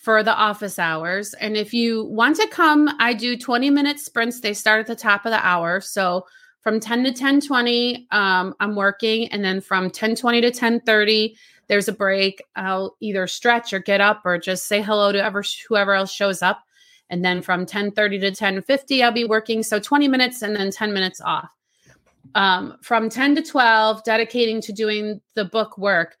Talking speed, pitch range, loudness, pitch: 200 wpm, 195-235 Hz, -19 LUFS, 215 Hz